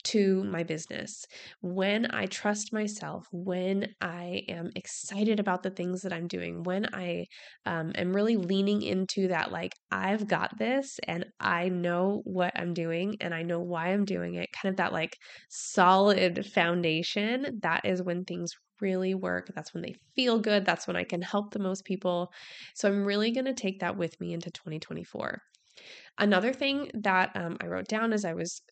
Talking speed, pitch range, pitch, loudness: 180 wpm, 175-205 Hz, 185 Hz, -30 LUFS